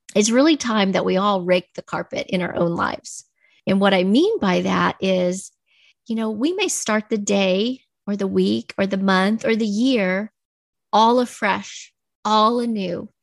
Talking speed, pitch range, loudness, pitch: 180 wpm, 190-235 Hz, -20 LUFS, 205 Hz